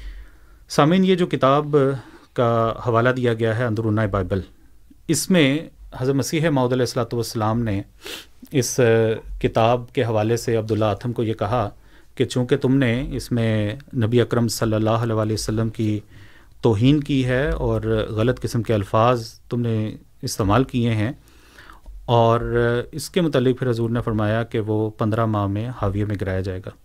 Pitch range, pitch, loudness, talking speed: 110-130 Hz, 115 Hz, -21 LUFS, 165 wpm